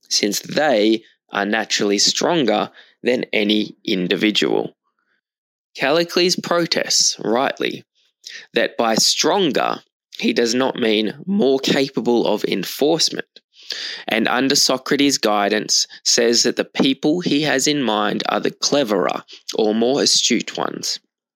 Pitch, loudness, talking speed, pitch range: 120 Hz, -18 LUFS, 115 wpm, 105-145 Hz